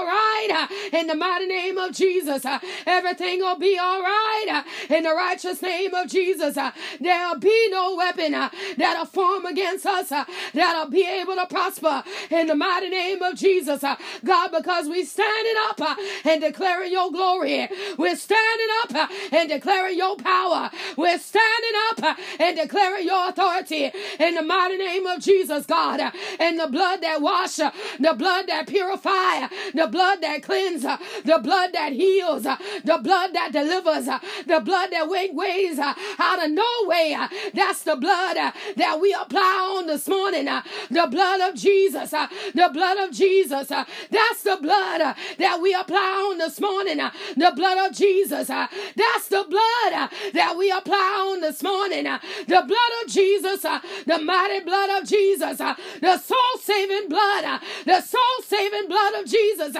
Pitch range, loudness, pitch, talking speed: 330-390 Hz, -22 LUFS, 370 Hz, 155 wpm